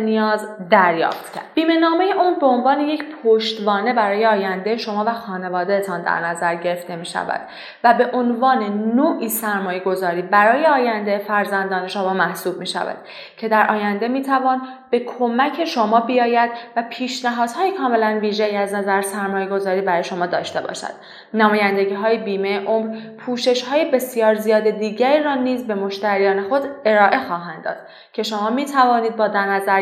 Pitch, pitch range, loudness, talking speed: 220 Hz, 200-245 Hz, -19 LUFS, 155 wpm